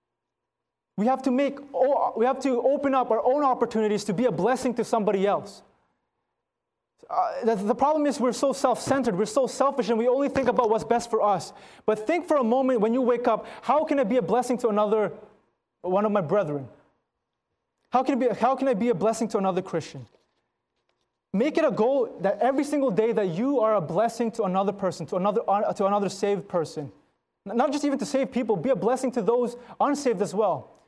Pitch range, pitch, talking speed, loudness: 210-260 Hz, 235 Hz, 205 wpm, -25 LUFS